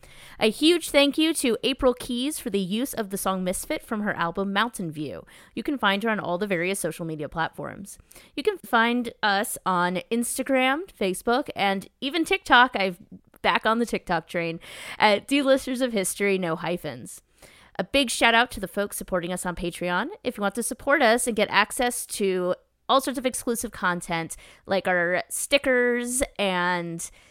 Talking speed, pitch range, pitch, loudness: 180 wpm, 180-250 Hz, 210 Hz, -24 LUFS